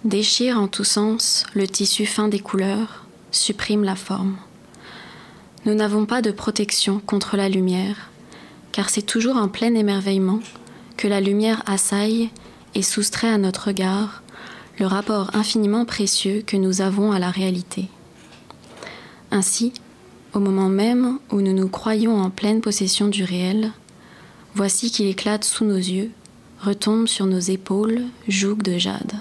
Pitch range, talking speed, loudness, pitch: 195-220 Hz, 145 wpm, -20 LUFS, 205 Hz